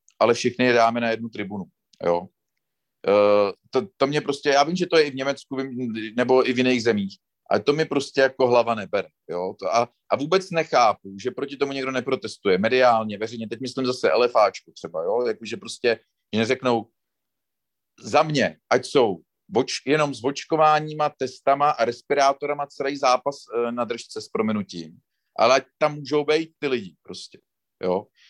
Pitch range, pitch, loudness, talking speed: 115-145 Hz, 130 Hz, -23 LUFS, 175 wpm